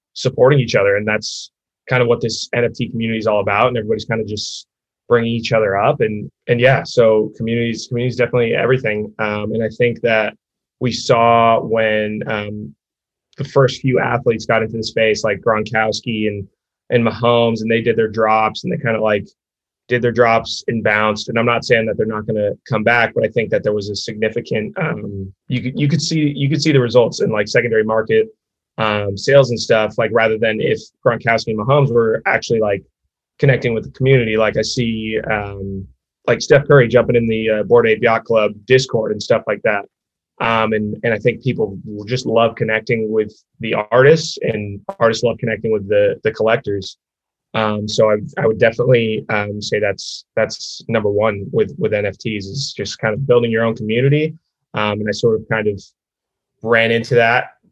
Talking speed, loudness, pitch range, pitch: 200 wpm, -16 LUFS, 105-120 Hz, 115 Hz